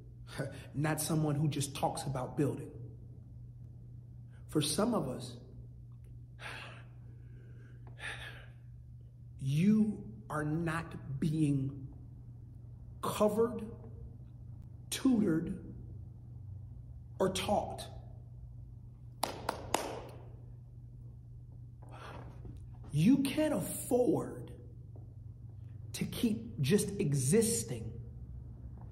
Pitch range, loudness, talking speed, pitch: 120-145 Hz, -34 LUFS, 55 wpm, 120 Hz